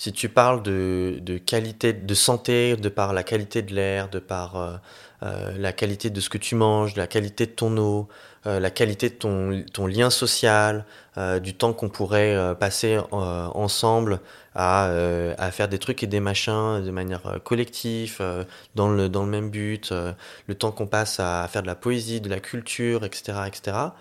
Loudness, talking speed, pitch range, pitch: -24 LUFS, 205 wpm, 95-115 Hz, 105 Hz